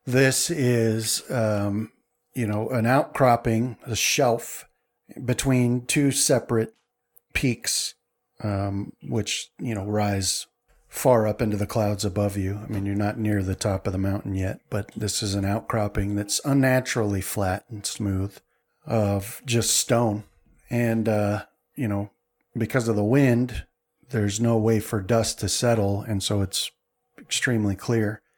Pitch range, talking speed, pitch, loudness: 100-120 Hz, 145 wpm, 110 Hz, -24 LUFS